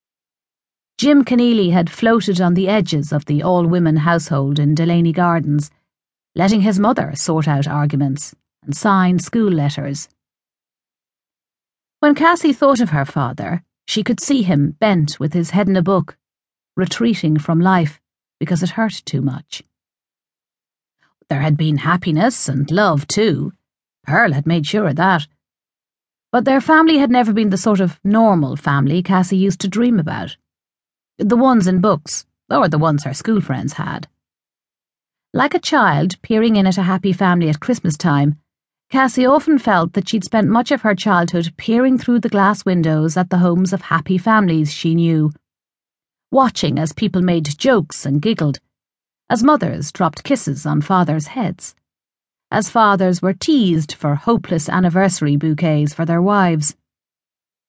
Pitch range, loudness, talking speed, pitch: 155-215 Hz, -16 LUFS, 155 wpm, 180 Hz